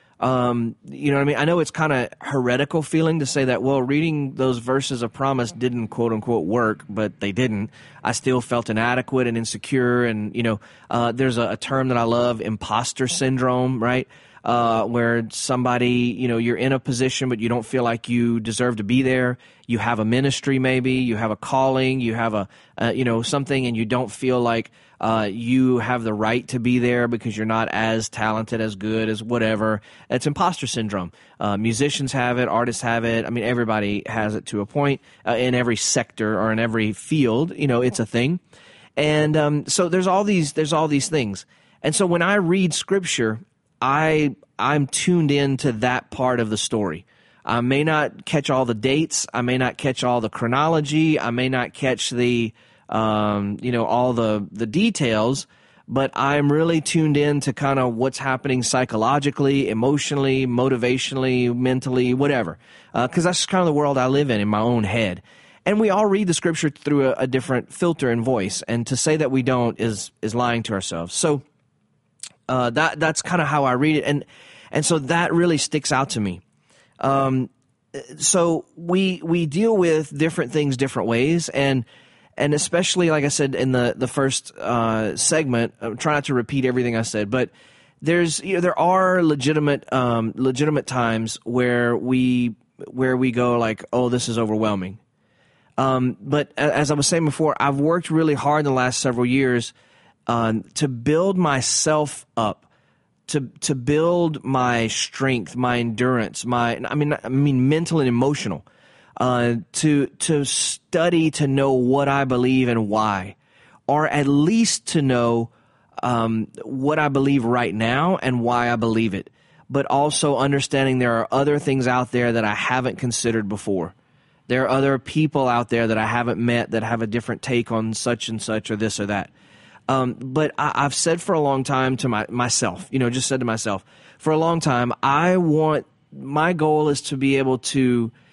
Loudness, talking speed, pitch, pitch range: -21 LUFS, 200 wpm, 130 Hz, 115-145 Hz